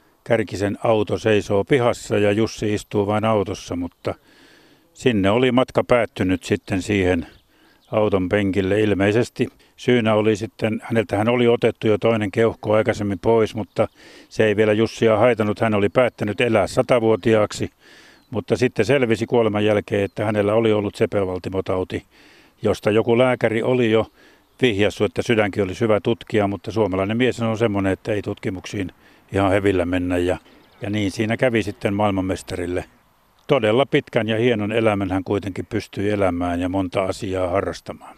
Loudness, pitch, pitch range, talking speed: -20 LUFS, 105 Hz, 100-115 Hz, 145 wpm